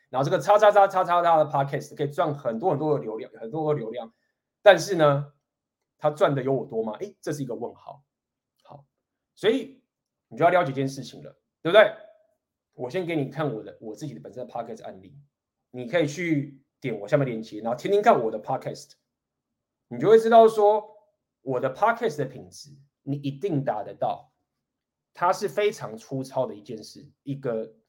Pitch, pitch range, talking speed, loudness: 145 Hz, 135-185 Hz, 320 characters per minute, -24 LUFS